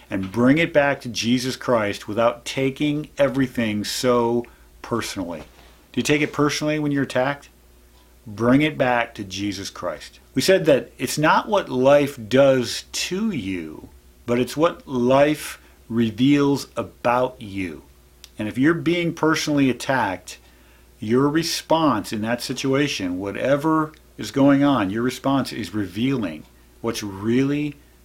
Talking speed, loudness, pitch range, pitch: 135 wpm, -21 LUFS, 105-145 Hz, 125 Hz